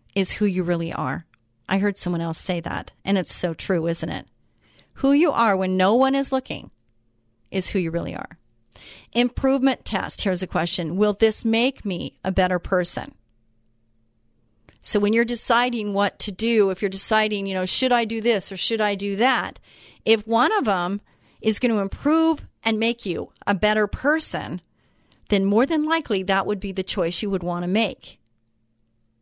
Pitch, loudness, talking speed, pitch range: 195 Hz, -22 LUFS, 185 wpm, 165-225 Hz